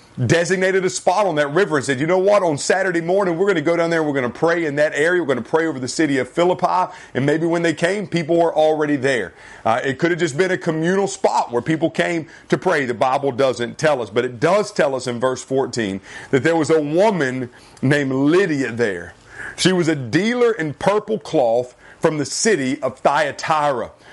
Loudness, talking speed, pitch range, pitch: -19 LUFS, 230 wpm, 135-180 Hz, 160 Hz